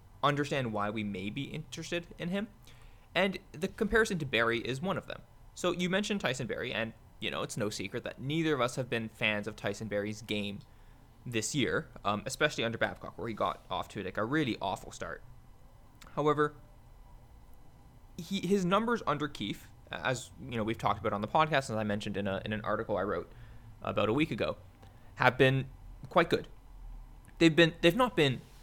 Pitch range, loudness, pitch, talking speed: 110-150 Hz, -32 LUFS, 120 Hz, 195 wpm